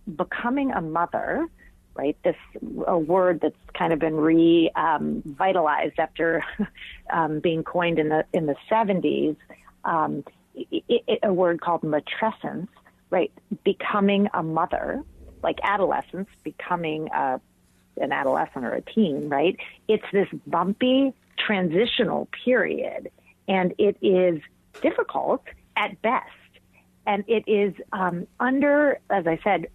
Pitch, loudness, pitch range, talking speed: 190 Hz, -24 LUFS, 165-220 Hz, 125 wpm